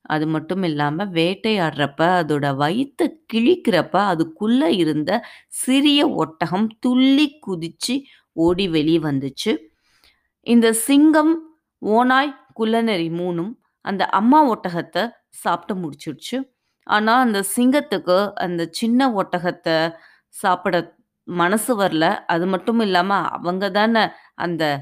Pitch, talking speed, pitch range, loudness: 195 Hz, 100 wpm, 170-250 Hz, -19 LUFS